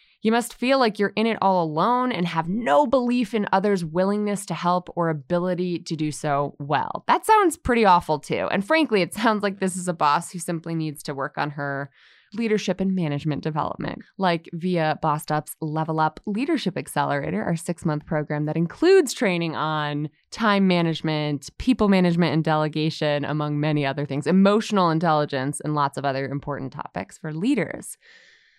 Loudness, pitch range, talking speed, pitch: -23 LUFS, 150-205 Hz, 175 wpm, 170 Hz